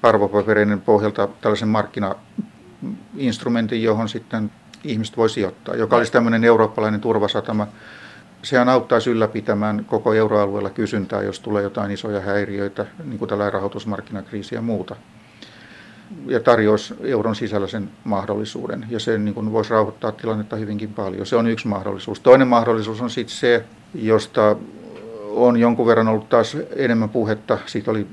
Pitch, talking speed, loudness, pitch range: 110 Hz, 135 wpm, -20 LUFS, 105-115 Hz